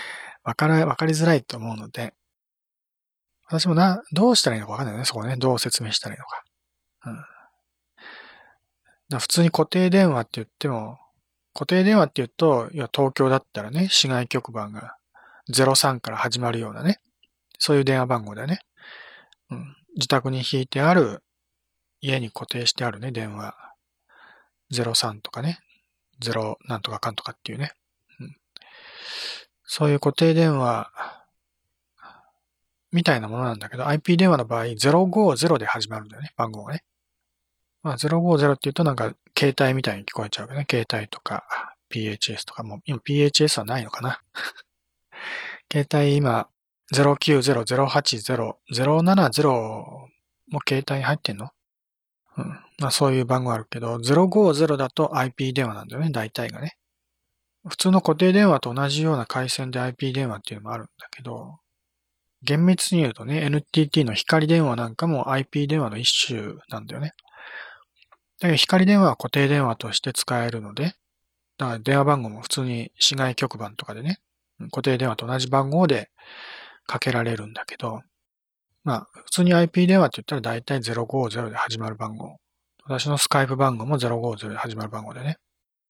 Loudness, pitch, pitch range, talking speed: -22 LUFS, 135 Hz, 115-155 Hz, 300 characters per minute